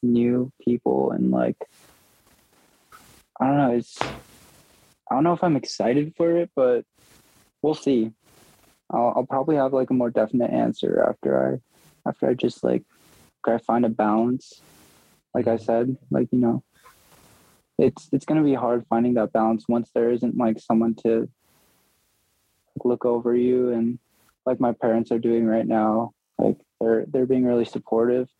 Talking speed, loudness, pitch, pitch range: 165 wpm, -23 LUFS, 120 Hz, 115-125 Hz